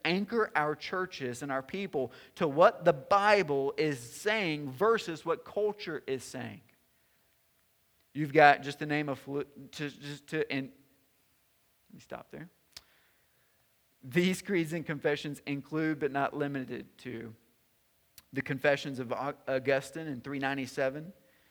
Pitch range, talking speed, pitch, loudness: 135-165 Hz, 135 wpm, 145 Hz, -31 LUFS